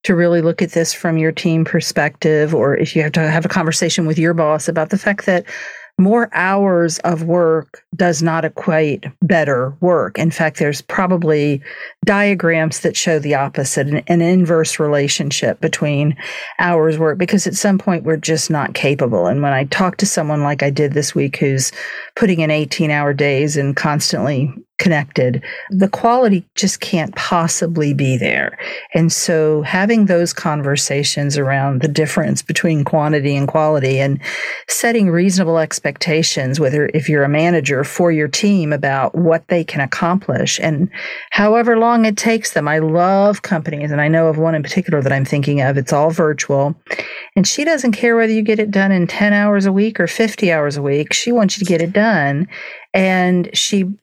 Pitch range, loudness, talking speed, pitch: 150-185 Hz, -15 LUFS, 180 wpm, 165 Hz